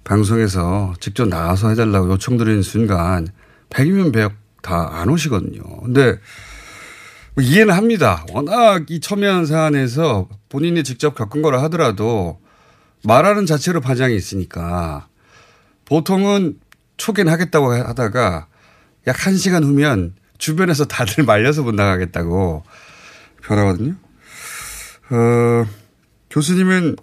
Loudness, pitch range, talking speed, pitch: -16 LUFS, 100-155 Hz, 265 characters per minute, 120 Hz